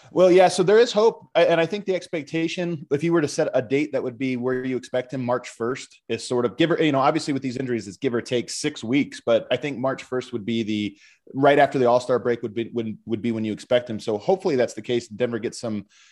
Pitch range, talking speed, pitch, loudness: 120-165 Hz, 270 wpm, 130 Hz, -23 LUFS